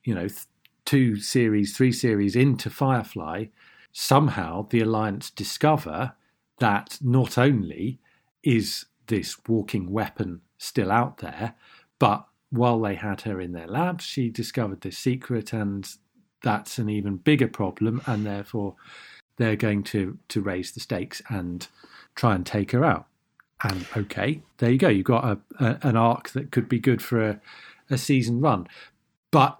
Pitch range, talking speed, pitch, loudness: 105-125 Hz, 155 wpm, 115 Hz, -25 LUFS